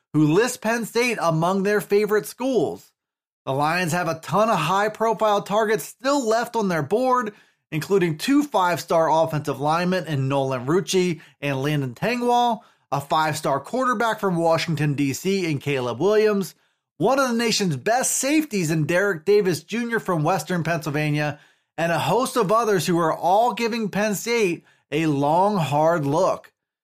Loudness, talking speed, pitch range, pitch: -22 LUFS, 155 wpm, 155-220 Hz, 185 Hz